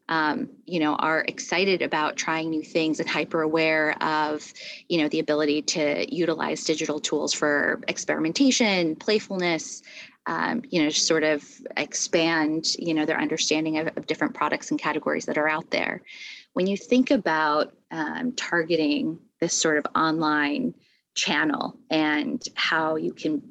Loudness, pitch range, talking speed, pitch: -24 LUFS, 155-175 Hz, 150 wpm, 160 Hz